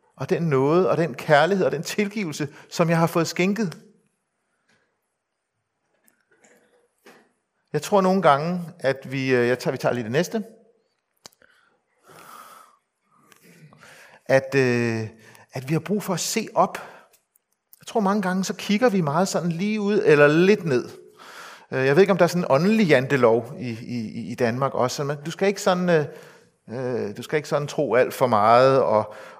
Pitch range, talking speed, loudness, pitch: 135-205 Hz, 160 wpm, -22 LUFS, 170 Hz